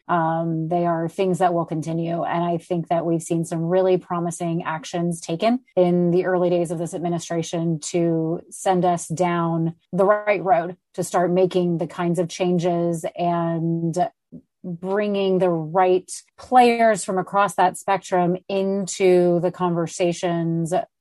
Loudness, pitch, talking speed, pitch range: -22 LUFS, 175 Hz, 145 wpm, 170-185 Hz